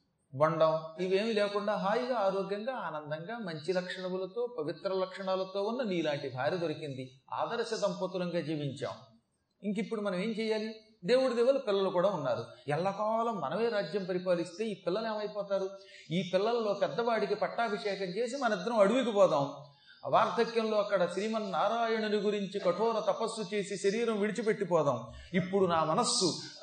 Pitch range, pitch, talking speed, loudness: 180-220 Hz, 200 Hz, 125 wpm, -32 LUFS